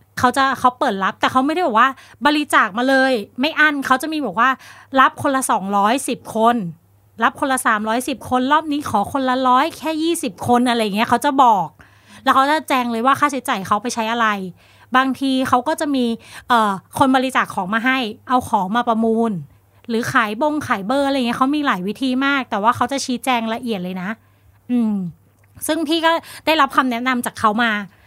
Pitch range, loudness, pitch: 225-275 Hz, -18 LUFS, 255 Hz